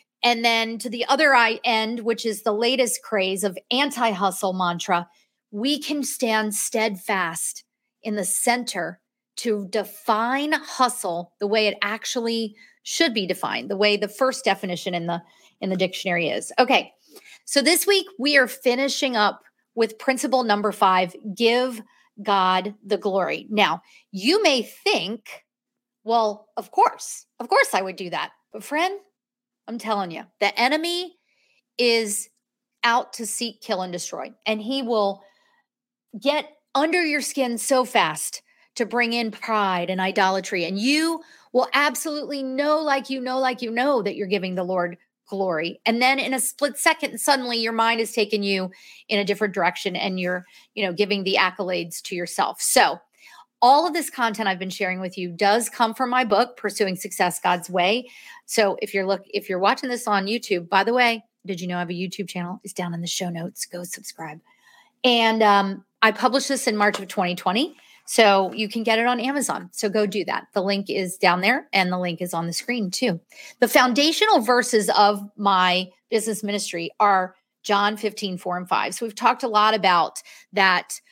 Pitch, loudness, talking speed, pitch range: 220 Hz, -22 LUFS, 180 wpm, 195-250 Hz